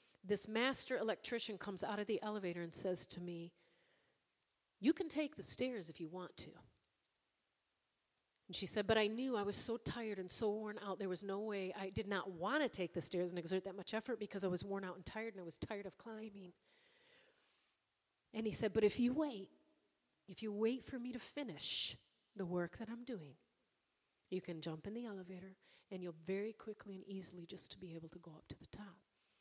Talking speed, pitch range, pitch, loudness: 215 wpm, 185-225 Hz, 200 Hz, -42 LUFS